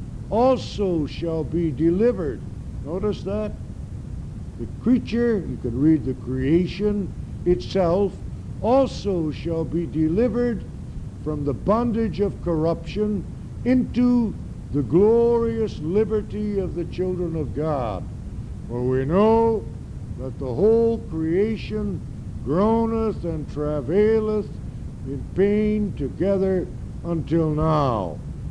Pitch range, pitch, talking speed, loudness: 150-215 Hz, 175 Hz, 100 wpm, -23 LUFS